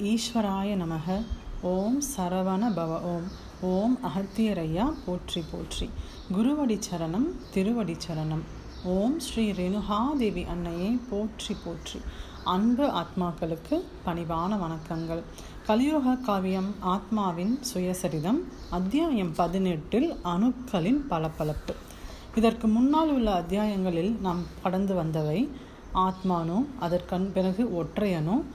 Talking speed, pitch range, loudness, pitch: 90 wpm, 175-230 Hz, -28 LUFS, 190 Hz